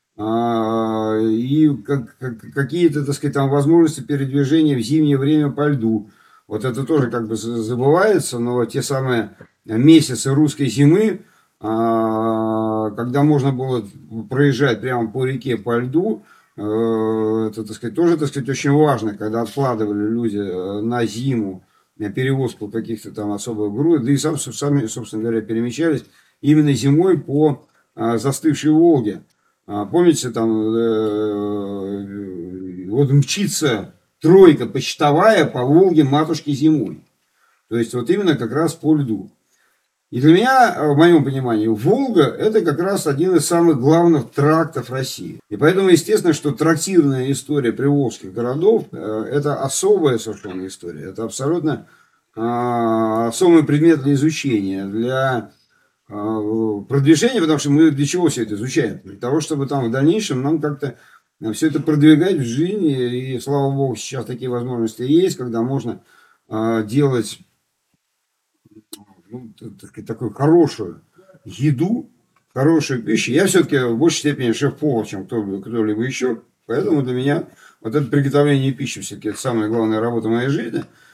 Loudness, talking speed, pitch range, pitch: -18 LUFS, 135 wpm, 110-150 Hz, 130 Hz